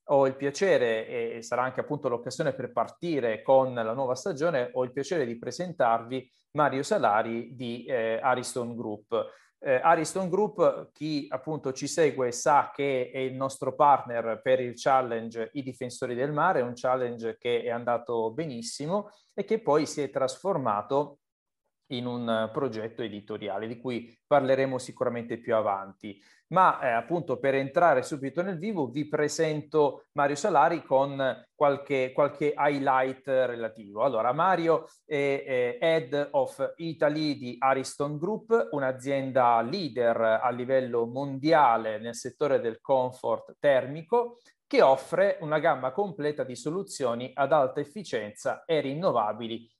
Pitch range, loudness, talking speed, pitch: 120-155 Hz, -28 LUFS, 140 wpm, 135 Hz